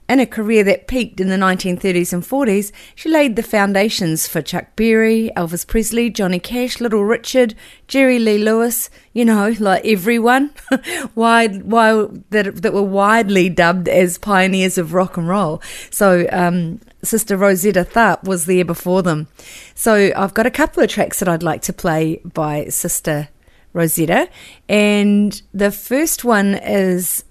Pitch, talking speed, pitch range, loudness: 200 Hz, 160 wpm, 180-225 Hz, -16 LUFS